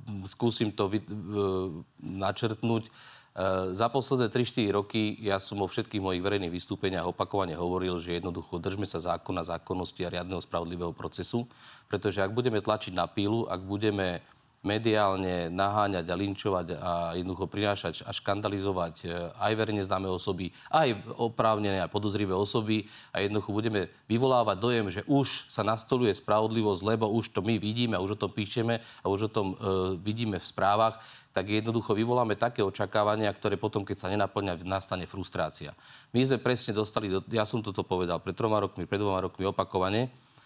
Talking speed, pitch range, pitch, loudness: 160 wpm, 95-110 Hz, 100 Hz, -30 LUFS